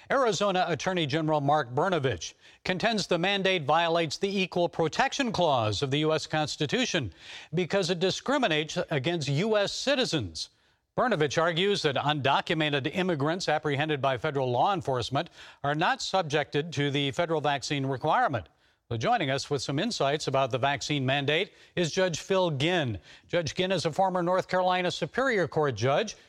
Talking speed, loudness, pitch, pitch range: 150 wpm, -27 LUFS, 160 Hz, 145-185 Hz